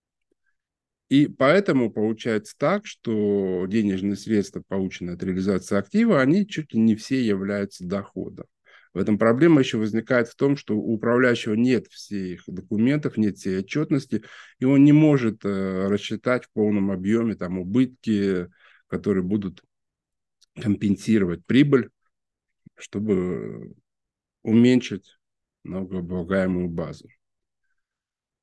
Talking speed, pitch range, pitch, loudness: 110 wpm, 95-125 Hz, 110 Hz, -23 LUFS